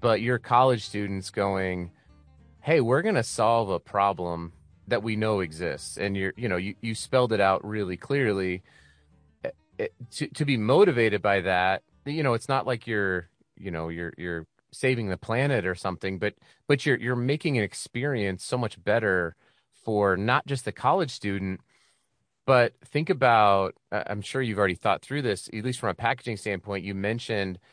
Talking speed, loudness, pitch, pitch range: 180 wpm, -26 LUFS, 105 Hz, 95-125 Hz